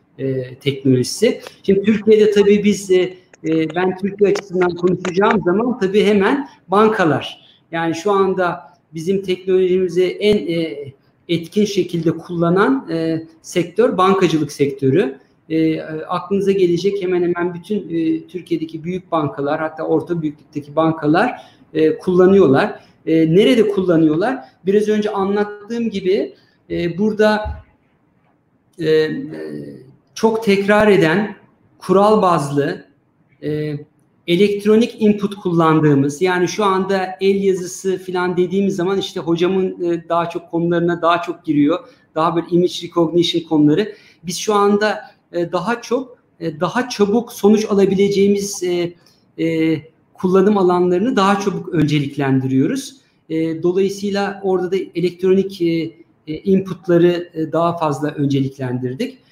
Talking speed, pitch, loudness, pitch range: 115 wpm, 180 Hz, -17 LUFS, 160-195 Hz